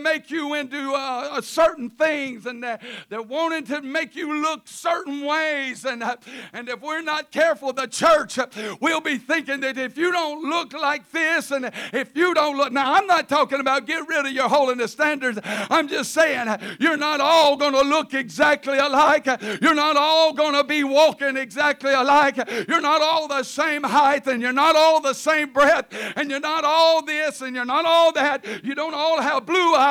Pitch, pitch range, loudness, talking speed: 290 Hz, 265-315 Hz, -20 LUFS, 200 wpm